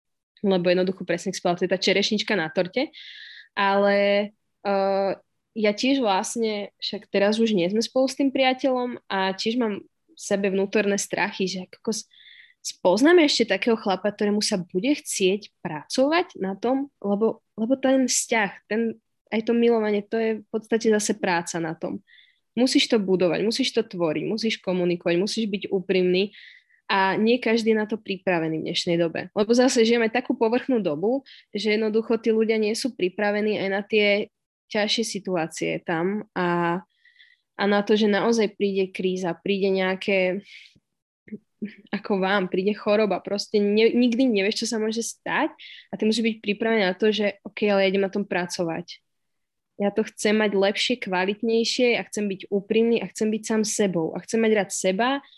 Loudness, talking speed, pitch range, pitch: -23 LUFS, 170 wpm, 195-230 Hz, 210 Hz